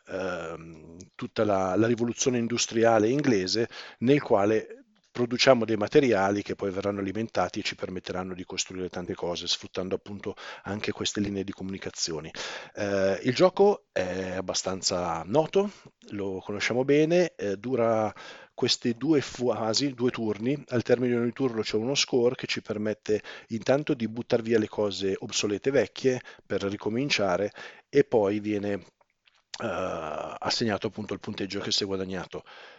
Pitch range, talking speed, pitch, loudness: 95-120 Hz, 145 wpm, 105 Hz, -27 LUFS